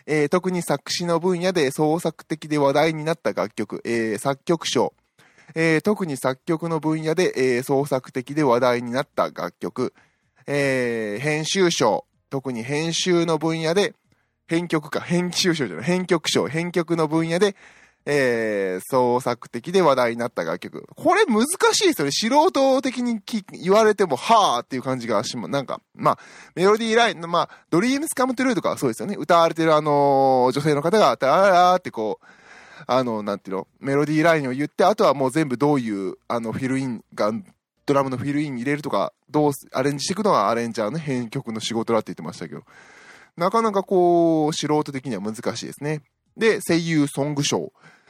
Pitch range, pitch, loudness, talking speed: 130-175 Hz, 150 Hz, -21 LUFS, 360 characters per minute